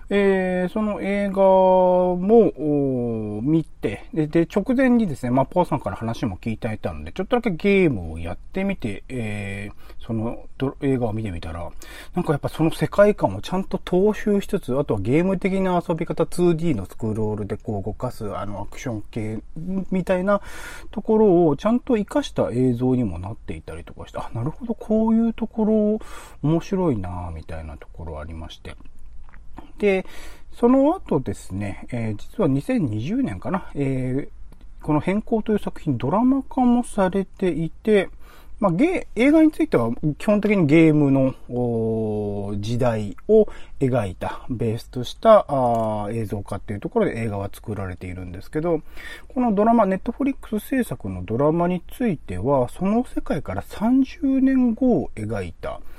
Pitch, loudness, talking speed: 150 Hz, -22 LUFS, 325 characters per minute